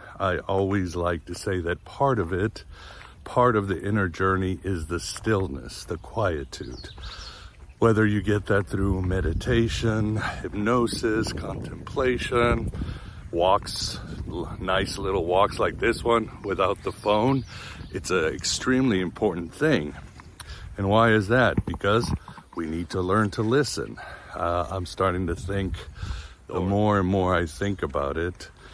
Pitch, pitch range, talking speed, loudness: 95 Hz, 85-110 Hz, 140 wpm, -25 LUFS